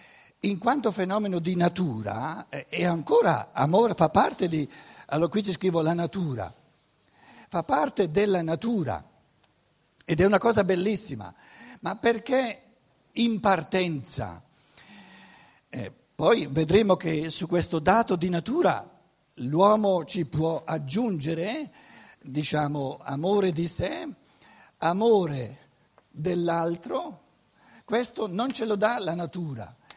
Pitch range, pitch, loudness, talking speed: 160-210 Hz, 180 Hz, -26 LUFS, 115 wpm